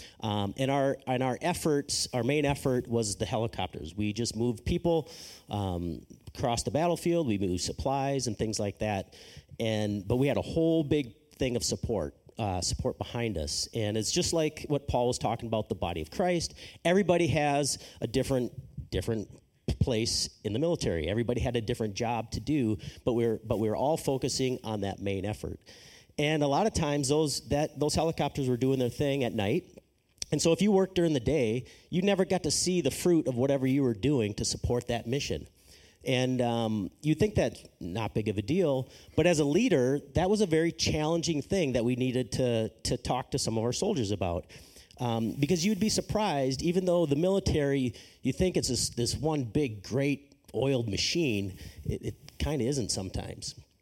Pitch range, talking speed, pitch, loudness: 110-150 Hz, 200 wpm, 125 Hz, -30 LUFS